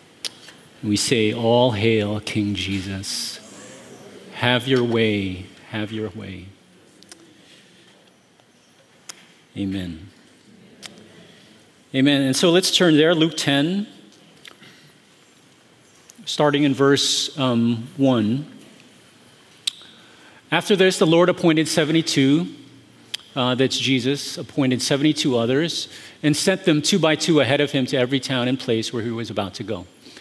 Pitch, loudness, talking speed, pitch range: 130 Hz, -20 LUFS, 115 wpm, 110-155 Hz